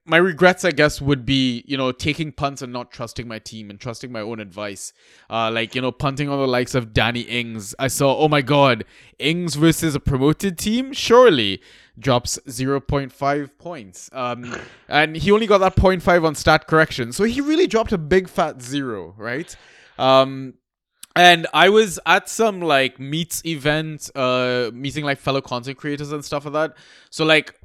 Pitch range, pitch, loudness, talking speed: 125-165 Hz, 140 Hz, -19 LUFS, 185 wpm